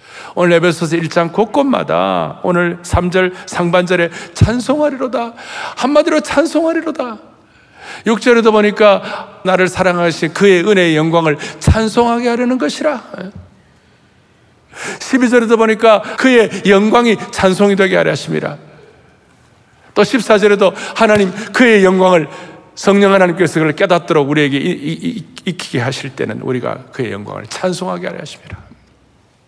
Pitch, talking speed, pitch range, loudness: 200 Hz, 290 characters per minute, 180-235 Hz, -13 LUFS